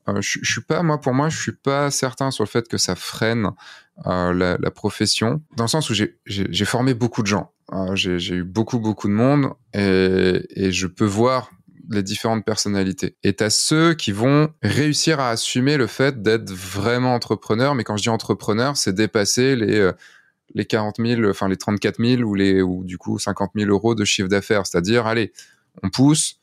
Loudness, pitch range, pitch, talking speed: -20 LUFS, 100-125 Hz, 110 Hz, 210 wpm